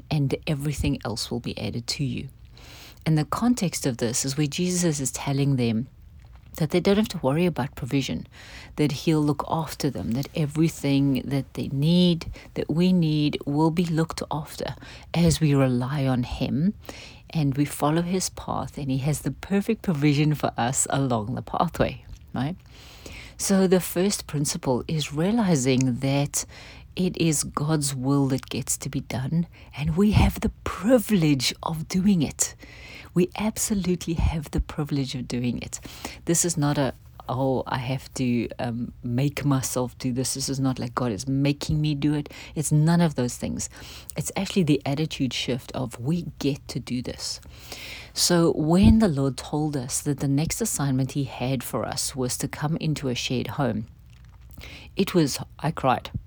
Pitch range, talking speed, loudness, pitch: 130-160 Hz, 175 wpm, -25 LUFS, 145 Hz